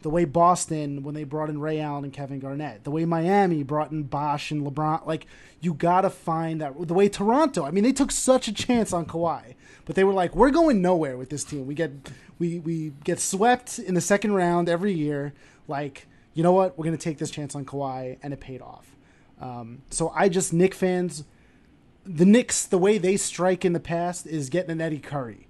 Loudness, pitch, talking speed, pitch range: -24 LUFS, 165 Hz, 220 wpm, 145-185 Hz